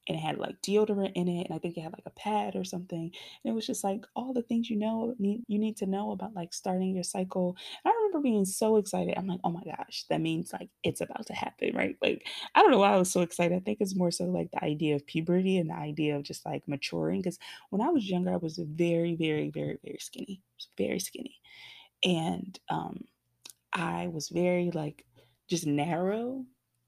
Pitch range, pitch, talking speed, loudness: 155-205 Hz, 180 Hz, 230 wpm, -31 LUFS